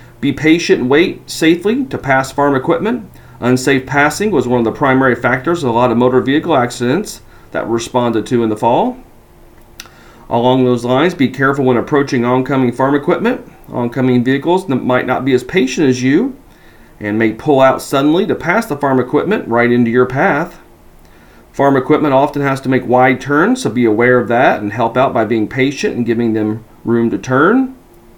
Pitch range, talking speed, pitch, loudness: 120-145 Hz, 190 wpm, 130 Hz, -13 LUFS